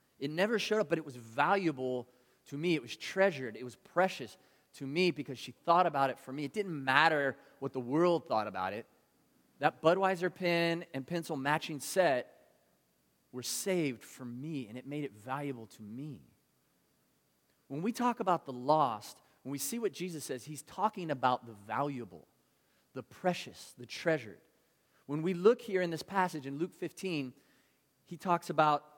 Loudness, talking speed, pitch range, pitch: -33 LUFS, 180 wpm, 130-175 Hz, 145 Hz